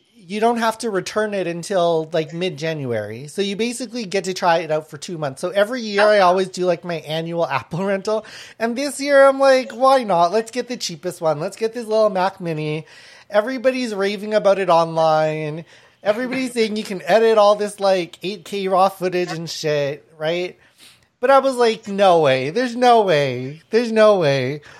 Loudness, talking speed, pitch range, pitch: -19 LUFS, 195 wpm, 165-225 Hz, 195 Hz